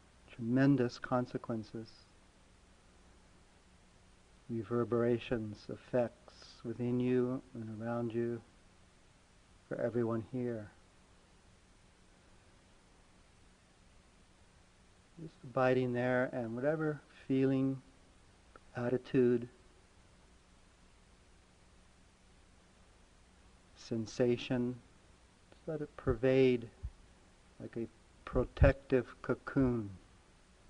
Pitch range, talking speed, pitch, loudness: 90-125 Hz, 55 wpm, 110 Hz, -35 LUFS